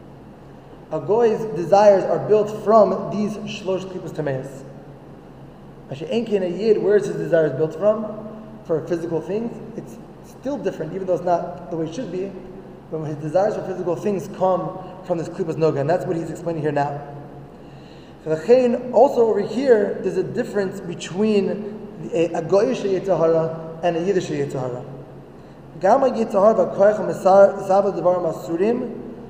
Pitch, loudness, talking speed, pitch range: 185 Hz, -20 LUFS, 165 wpm, 165-210 Hz